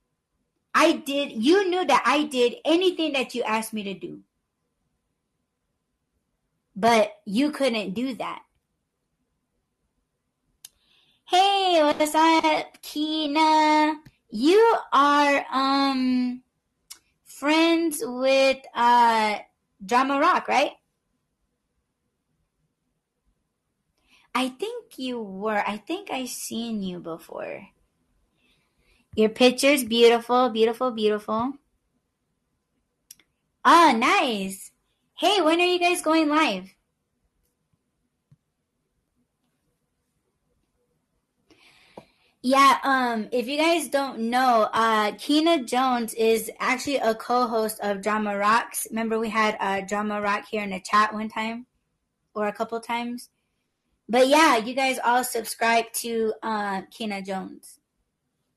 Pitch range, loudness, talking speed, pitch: 220-295 Hz, -22 LUFS, 100 wpm, 245 Hz